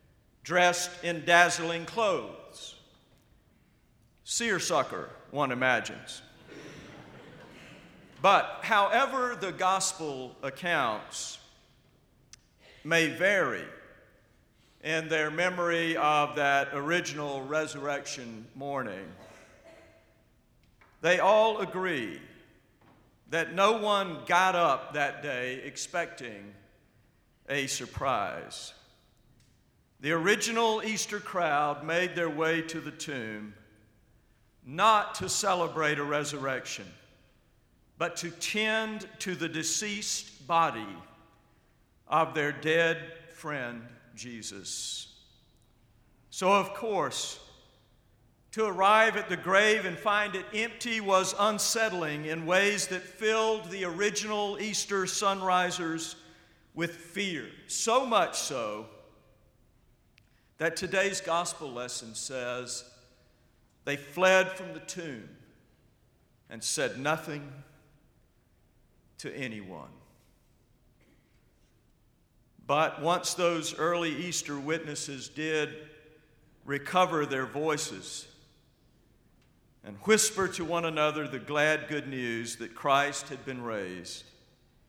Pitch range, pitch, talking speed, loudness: 135-185 Hz, 160 Hz, 90 wpm, -29 LUFS